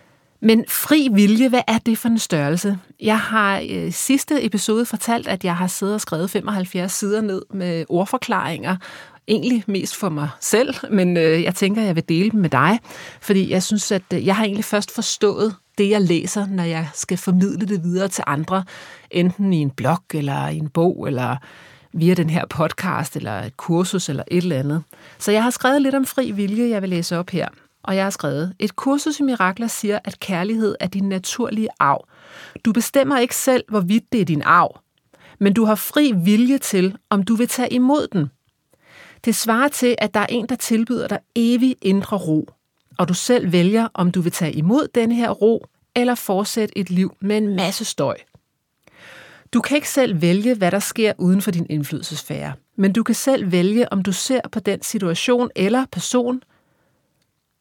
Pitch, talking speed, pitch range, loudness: 200 Hz, 195 wpm, 175-230 Hz, -19 LUFS